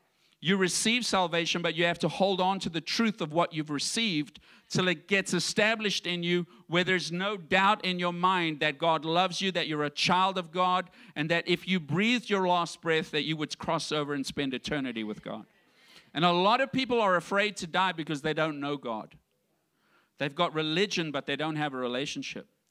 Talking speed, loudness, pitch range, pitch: 210 wpm, -28 LUFS, 155-190 Hz, 175 Hz